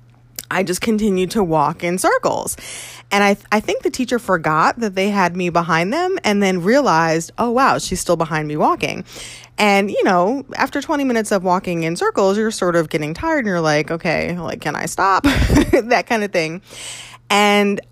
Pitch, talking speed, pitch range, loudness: 190 Hz, 200 wpm, 165-220 Hz, -17 LUFS